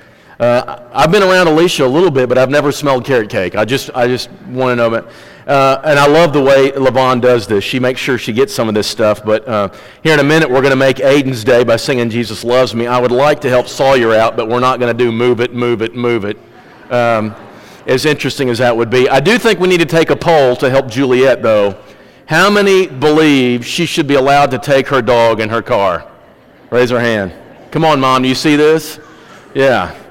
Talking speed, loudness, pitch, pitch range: 240 wpm, -11 LUFS, 130 Hz, 120-145 Hz